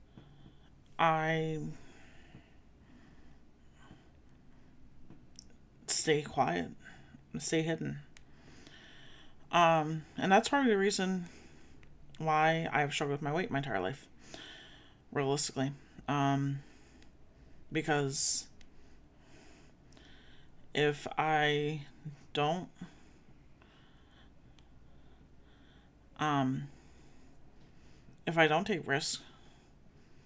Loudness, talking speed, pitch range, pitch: -32 LUFS, 65 wpm, 135-160 Hz, 145 Hz